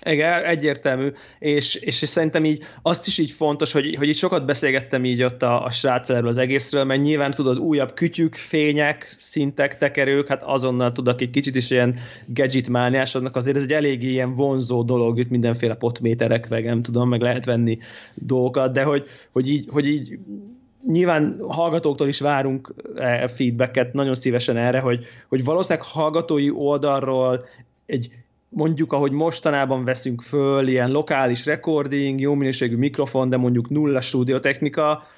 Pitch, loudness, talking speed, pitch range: 135 Hz, -21 LUFS, 150 wpm, 125-150 Hz